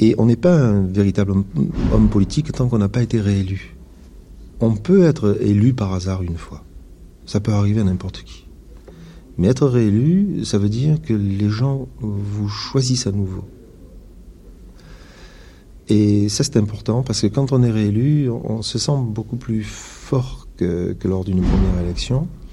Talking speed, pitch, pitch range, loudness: 170 wpm, 105 Hz, 95-125 Hz, -18 LUFS